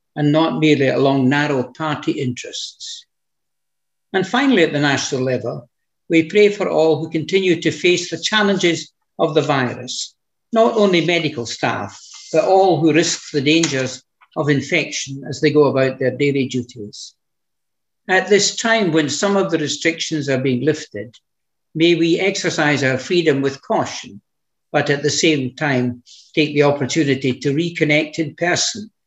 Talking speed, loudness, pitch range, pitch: 155 wpm, -17 LUFS, 135-170 Hz, 155 Hz